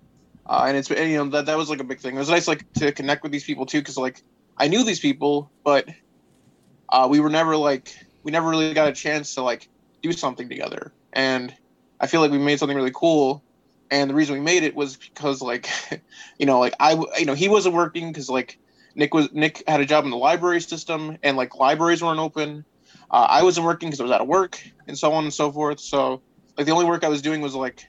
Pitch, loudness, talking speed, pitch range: 150 Hz, -21 LUFS, 250 wpm, 140-160 Hz